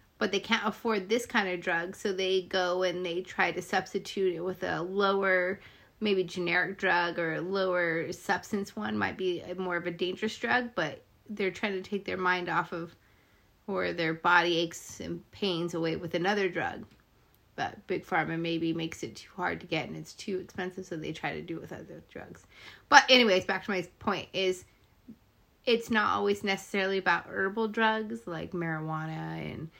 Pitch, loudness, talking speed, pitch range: 185 Hz, -30 LUFS, 190 wpm, 170-200 Hz